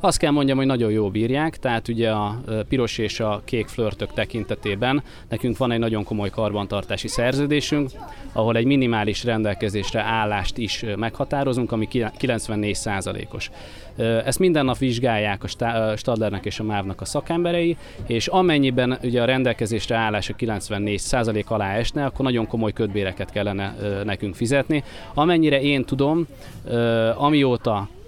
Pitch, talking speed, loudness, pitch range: 115 Hz, 140 wpm, -22 LUFS, 105-130 Hz